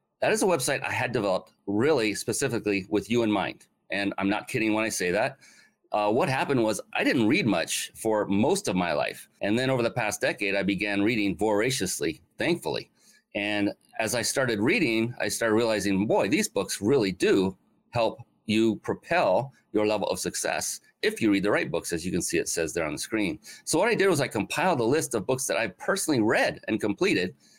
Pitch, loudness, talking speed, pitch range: 105 Hz, -26 LUFS, 215 wpm, 100-115 Hz